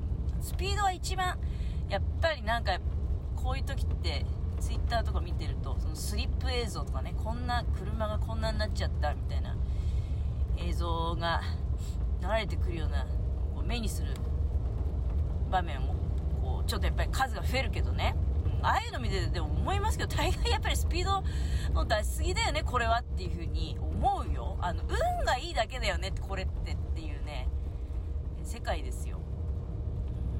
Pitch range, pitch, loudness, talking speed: 75-85 Hz, 80 Hz, -32 LUFS, 340 characters per minute